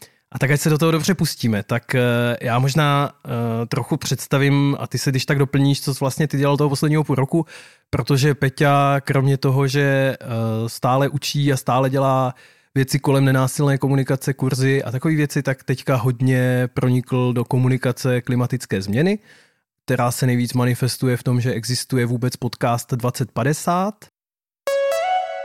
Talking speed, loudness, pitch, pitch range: 155 wpm, -20 LUFS, 135 Hz, 125-145 Hz